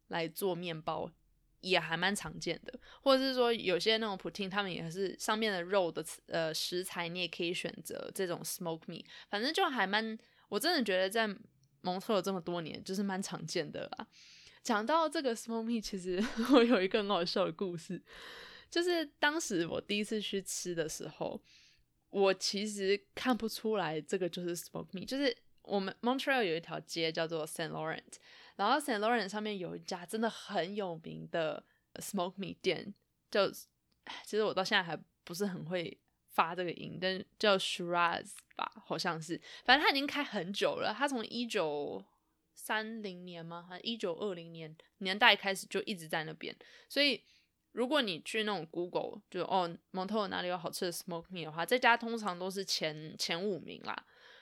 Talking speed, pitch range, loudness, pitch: 330 characters per minute, 175-225 Hz, -34 LUFS, 195 Hz